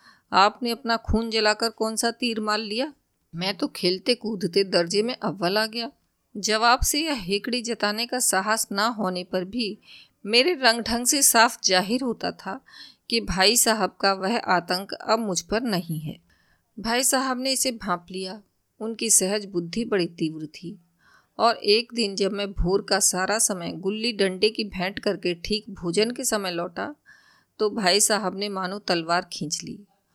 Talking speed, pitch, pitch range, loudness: 175 wpm, 210 Hz, 185-230 Hz, -23 LUFS